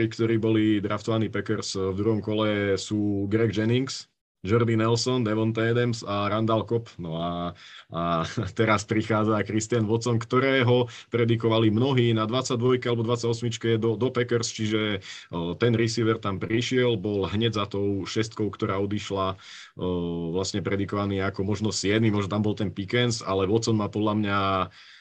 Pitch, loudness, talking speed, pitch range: 110 Hz, -25 LUFS, 150 wpm, 100-115 Hz